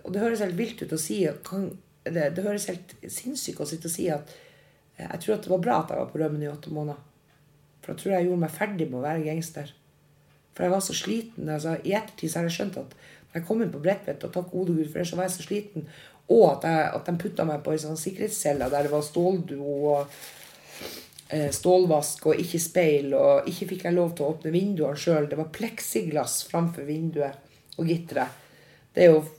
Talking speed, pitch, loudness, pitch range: 230 wpm, 165 Hz, -27 LUFS, 150-185 Hz